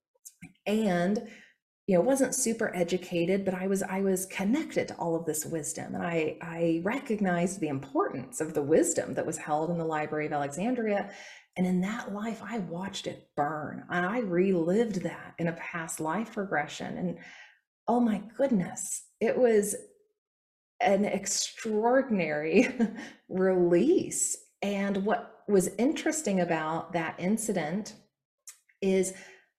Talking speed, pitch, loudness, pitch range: 140 wpm, 190 Hz, -29 LUFS, 170-225 Hz